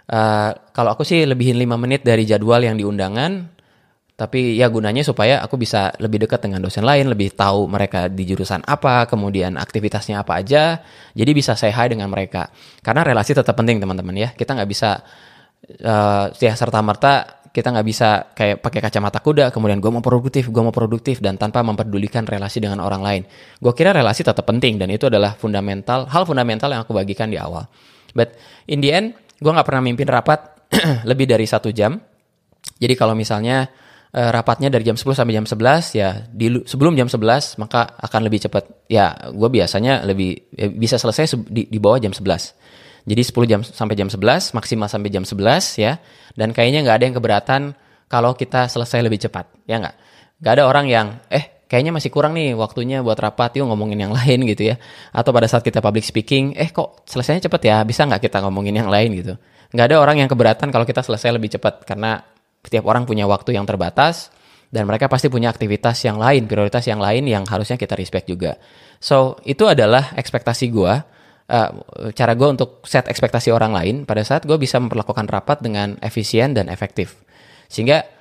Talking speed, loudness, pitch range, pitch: 190 wpm, -17 LUFS, 105-130 Hz, 115 Hz